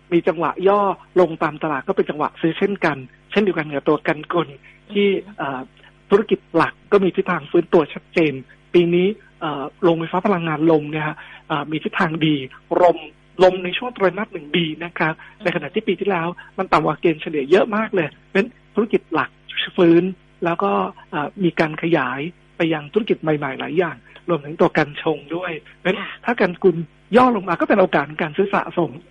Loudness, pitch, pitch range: -20 LUFS, 175 Hz, 155-190 Hz